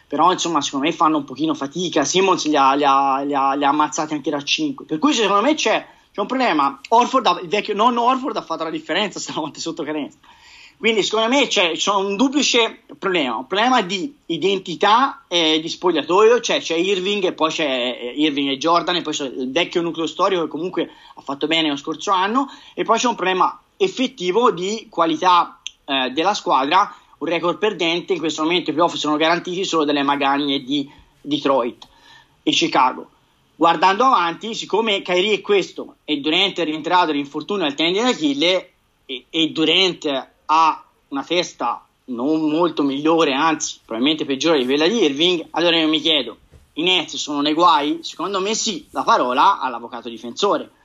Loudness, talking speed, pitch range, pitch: -18 LUFS, 185 wpm, 155-205 Hz, 170 Hz